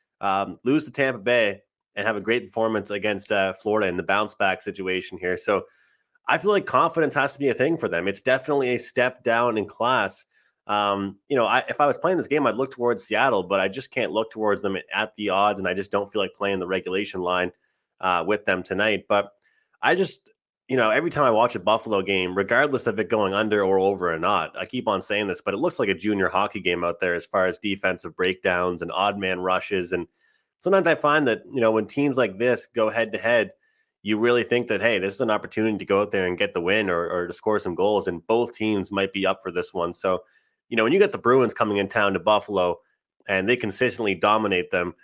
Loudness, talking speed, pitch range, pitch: -23 LUFS, 250 wpm, 95-120 Hz, 105 Hz